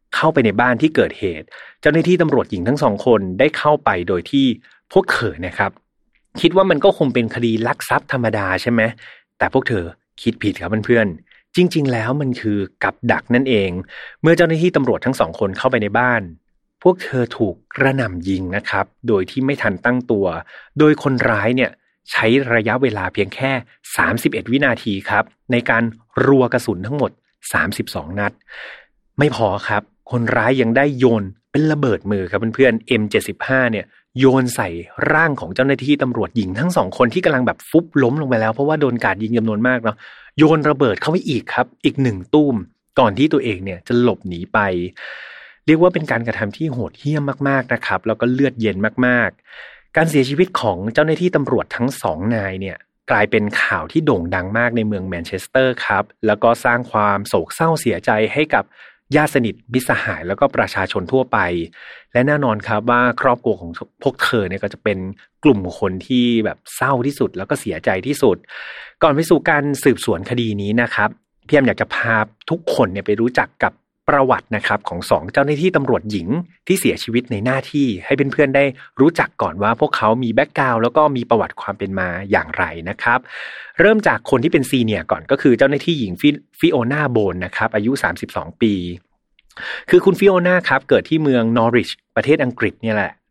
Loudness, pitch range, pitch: -17 LUFS, 105-140 Hz, 120 Hz